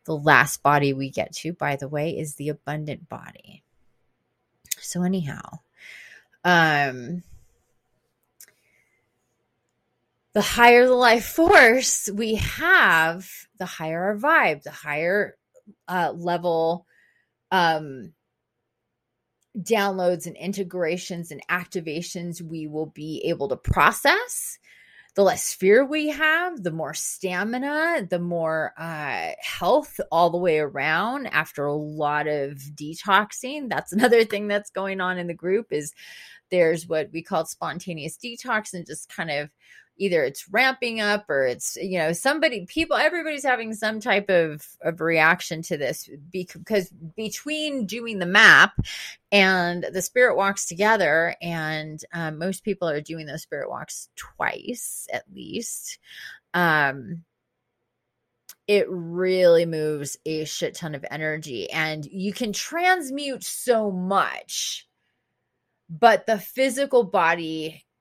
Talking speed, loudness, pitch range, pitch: 125 wpm, -22 LUFS, 155-215 Hz, 175 Hz